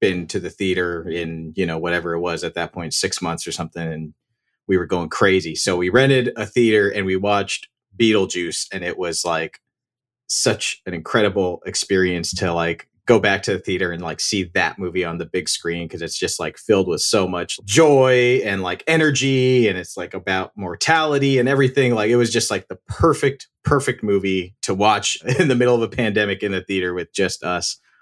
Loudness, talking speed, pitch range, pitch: -19 LUFS, 210 wpm, 90-125 Hz, 100 Hz